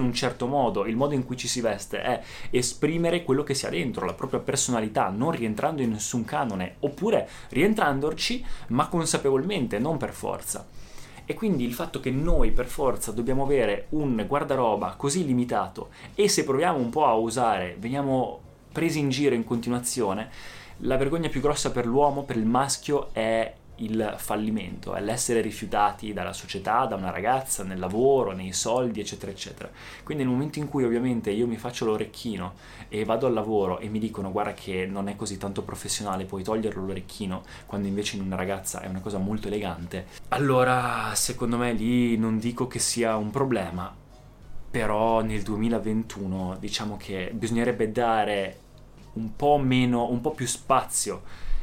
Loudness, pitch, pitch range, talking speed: -27 LUFS, 115 Hz, 105-130 Hz, 170 wpm